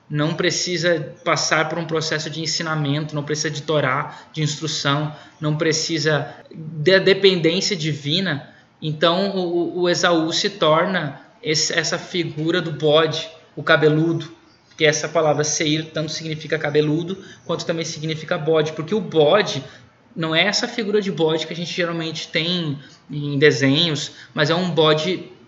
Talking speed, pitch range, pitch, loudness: 150 wpm, 155-175 Hz, 160 Hz, -20 LUFS